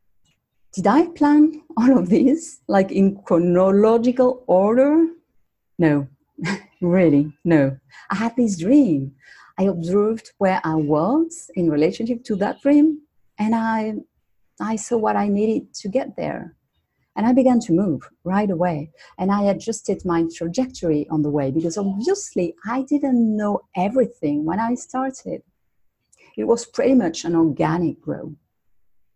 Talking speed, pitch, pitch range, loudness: 140 wpm, 205 Hz, 170-250 Hz, -20 LUFS